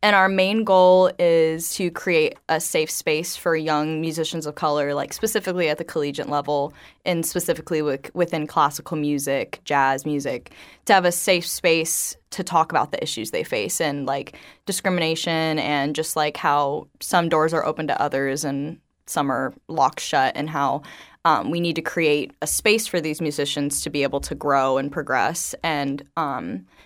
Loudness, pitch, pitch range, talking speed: -22 LUFS, 160 Hz, 145-175 Hz, 180 wpm